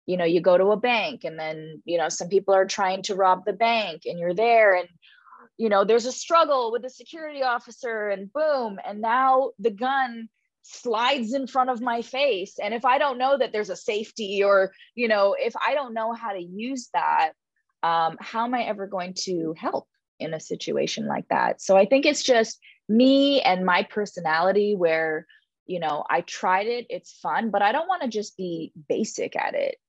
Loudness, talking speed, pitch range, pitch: -24 LUFS, 210 wpm, 190-260 Hz, 225 Hz